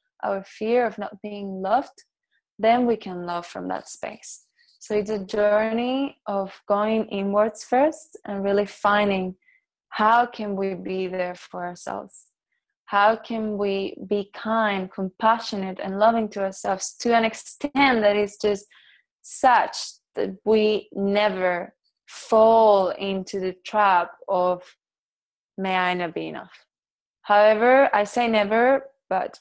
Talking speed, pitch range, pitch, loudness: 135 wpm, 195-225 Hz, 210 Hz, -23 LUFS